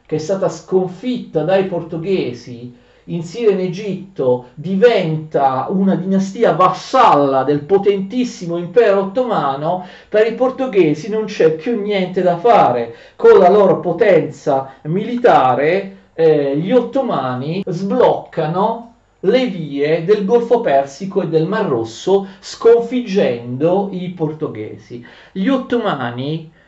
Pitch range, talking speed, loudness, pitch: 155-215 Hz, 110 wpm, -16 LUFS, 185 Hz